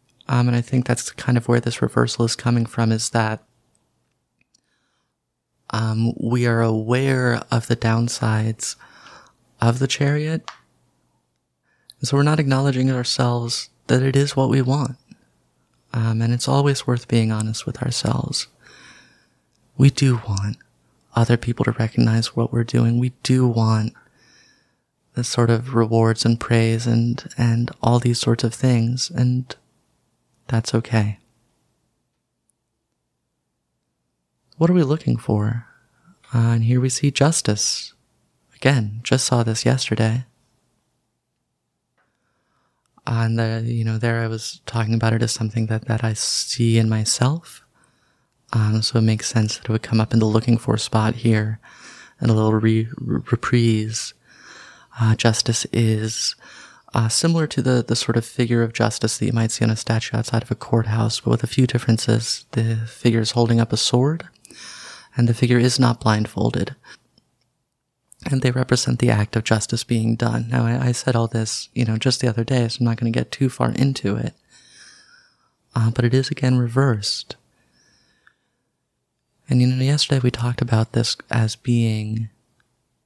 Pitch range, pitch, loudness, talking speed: 115-125 Hz, 115 Hz, -20 LUFS, 160 wpm